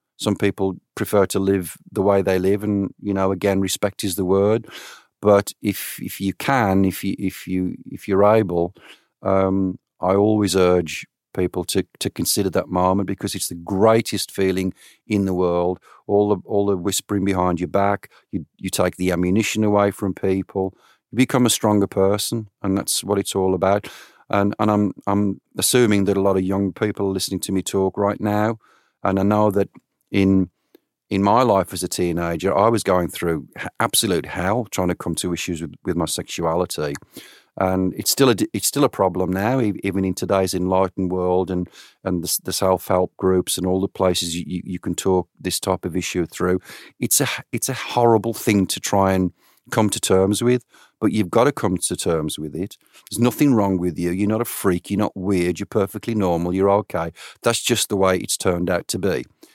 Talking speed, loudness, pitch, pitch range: 200 wpm, -21 LUFS, 95 Hz, 95-105 Hz